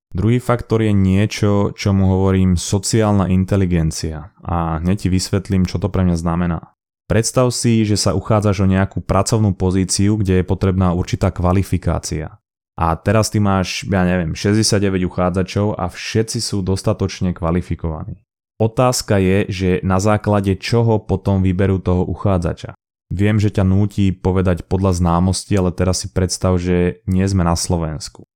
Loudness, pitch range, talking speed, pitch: -17 LUFS, 90-105 Hz, 150 wpm, 95 Hz